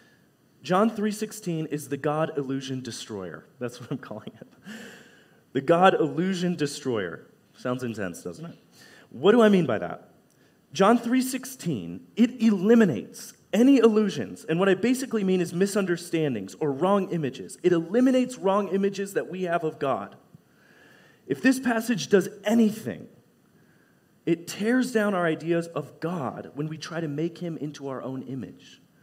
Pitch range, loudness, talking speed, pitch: 150-215 Hz, -25 LUFS, 150 wpm, 175 Hz